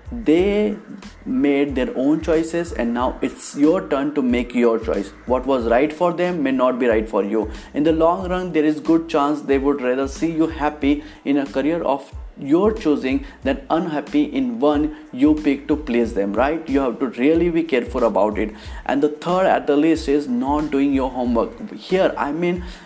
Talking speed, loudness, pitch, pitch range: 200 wpm, -20 LUFS, 150 Hz, 130-165 Hz